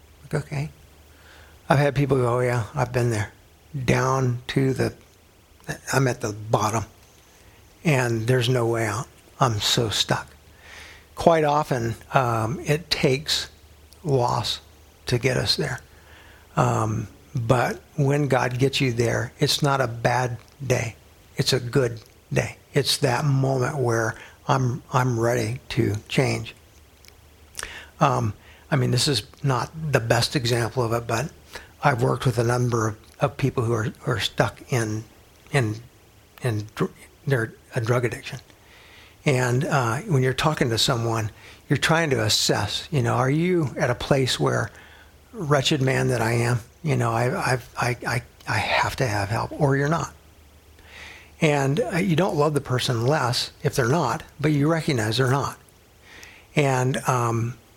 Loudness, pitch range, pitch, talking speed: -23 LUFS, 105-135 Hz, 120 Hz, 160 wpm